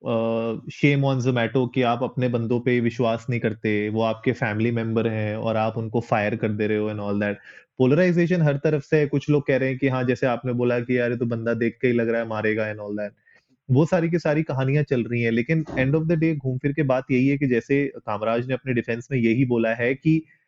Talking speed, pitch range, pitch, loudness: 245 wpm, 115-140 Hz, 125 Hz, -23 LUFS